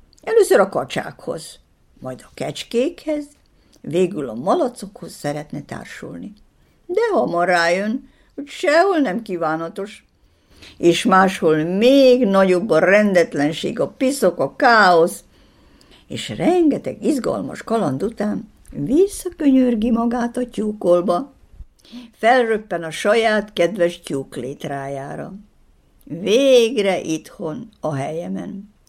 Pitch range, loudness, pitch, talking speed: 170-250 Hz, -18 LUFS, 210 Hz, 100 wpm